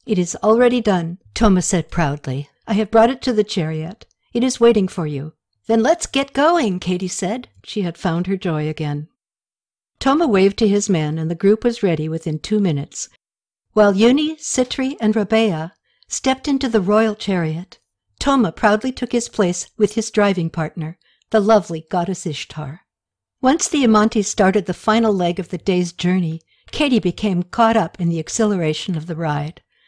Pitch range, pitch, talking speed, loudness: 170-225 Hz, 200 Hz, 175 wpm, -18 LUFS